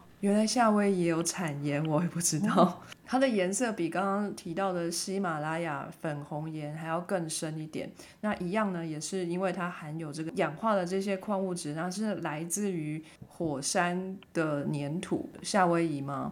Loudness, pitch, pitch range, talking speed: -31 LUFS, 175 Hz, 160-195 Hz, 260 characters per minute